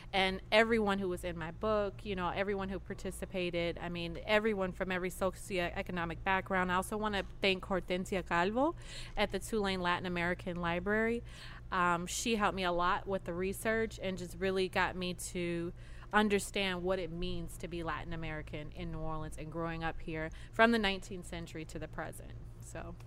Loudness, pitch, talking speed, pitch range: -35 LUFS, 180 Hz, 180 wpm, 170-195 Hz